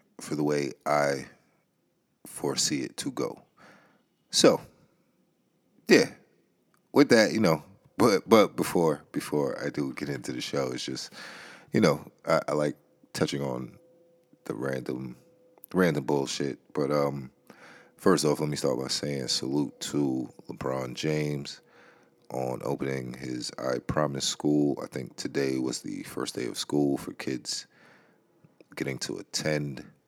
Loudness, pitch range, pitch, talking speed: -28 LUFS, 65-75 Hz, 70 Hz, 140 wpm